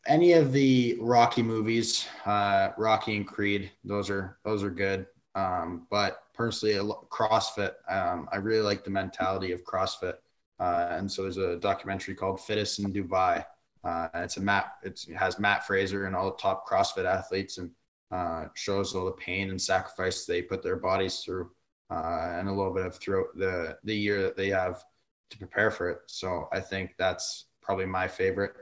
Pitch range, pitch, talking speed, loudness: 95-105 Hz, 100 Hz, 185 wpm, -29 LUFS